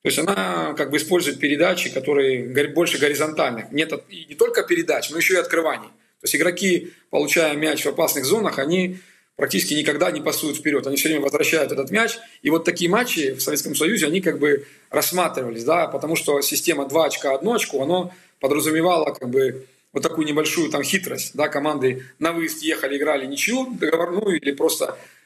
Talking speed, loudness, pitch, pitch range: 185 wpm, -21 LUFS, 160 Hz, 145-180 Hz